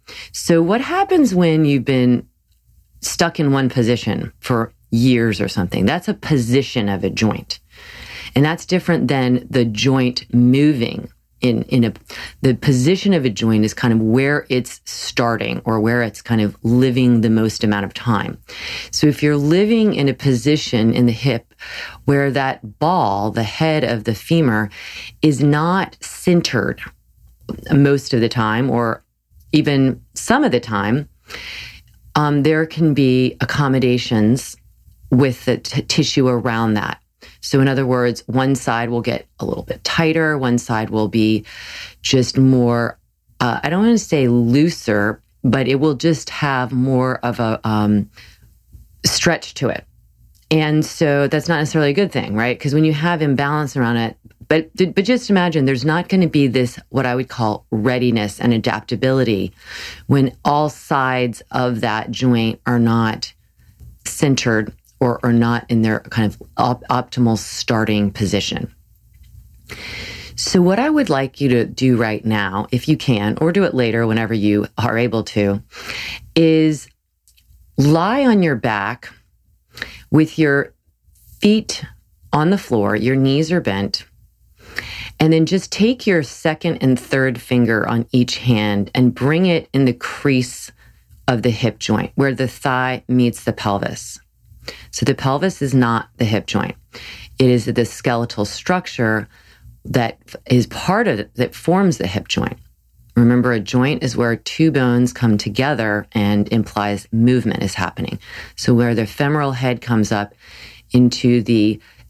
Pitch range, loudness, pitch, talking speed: 115-145 Hz, -17 LUFS, 125 Hz, 155 wpm